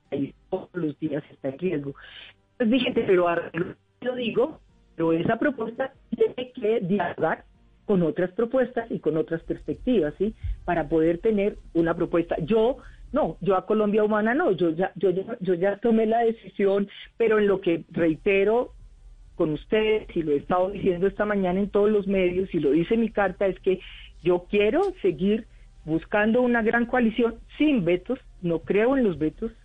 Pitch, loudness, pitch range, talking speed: 200 Hz, -25 LUFS, 170-230 Hz, 180 wpm